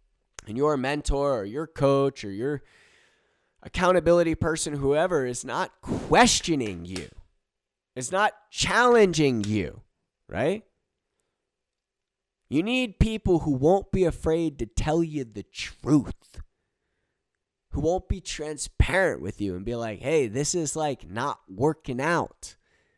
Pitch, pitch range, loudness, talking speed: 150 Hz, 125-185 Hz, -25 LUFS, 125 wpm